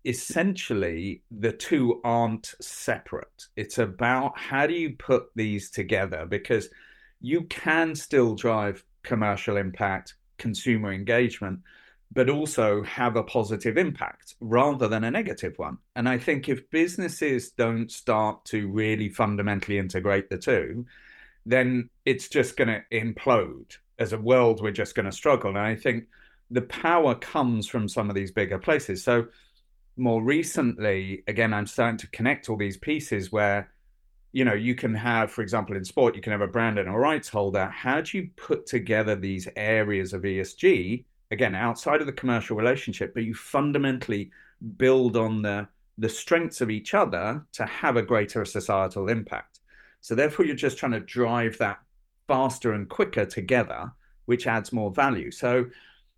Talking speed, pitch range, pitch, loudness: 160 wpm, 105-125 Hz, 115 Hz, -26 LUFS